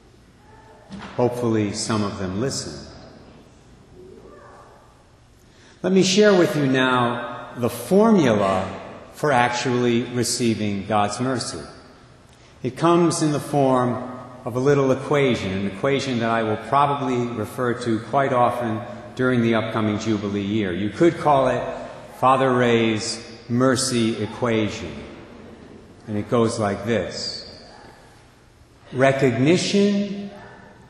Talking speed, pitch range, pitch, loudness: 110 wpm, 110-135 Hz, 120 Hz, -21 LUFS